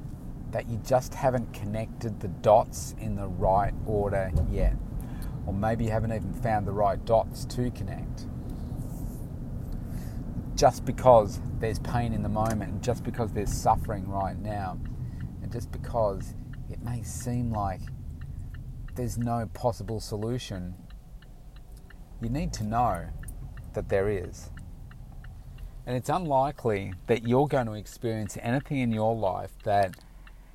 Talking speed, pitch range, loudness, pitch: 135 wpm, 100-120 Hz, -29 LUFS, 110 Hz